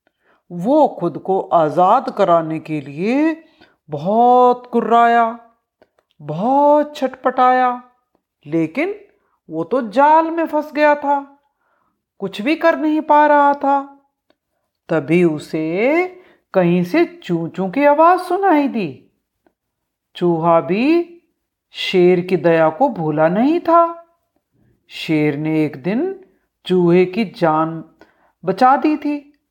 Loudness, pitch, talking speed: -16 LUFS, 250 Hz, 110 wpm